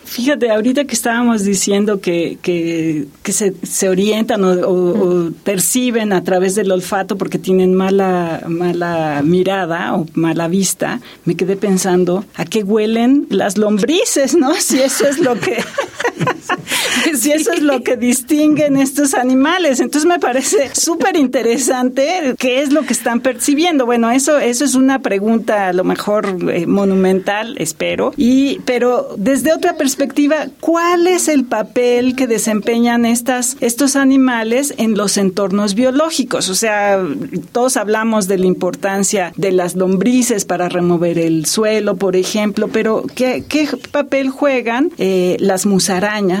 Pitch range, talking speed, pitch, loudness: 190-265 Hz, 150 wpm, 225 Hz, -14 LUFS